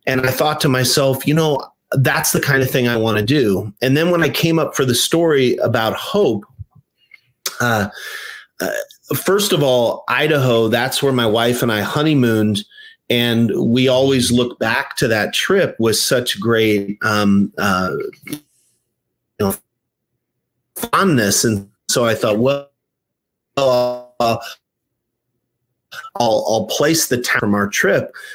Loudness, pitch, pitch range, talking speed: -16 LUFS, 125 Hz, 115-150 Hz, 150 wpm